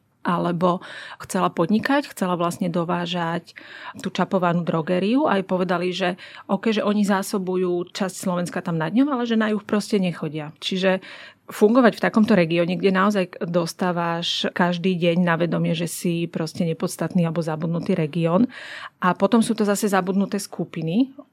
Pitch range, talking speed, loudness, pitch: 170-200 Hz, 150 wpm, -22 LUFS, 180 Hz